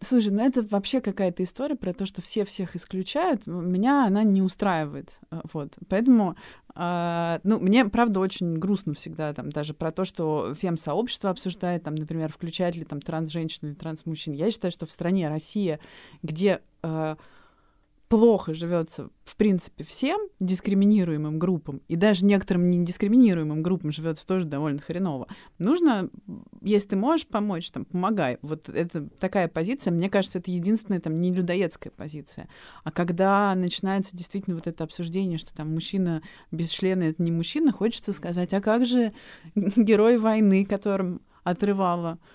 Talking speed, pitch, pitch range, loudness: 150 wpm, 185 Hz, 165-205 Hz, -25 LUFS